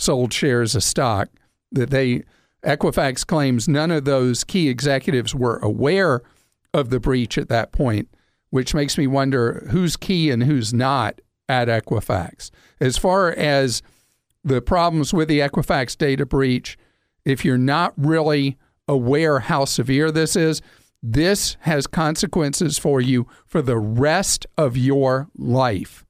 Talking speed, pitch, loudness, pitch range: 145 wpm, 140 Hz, -20 LUFS, 125-155 Hz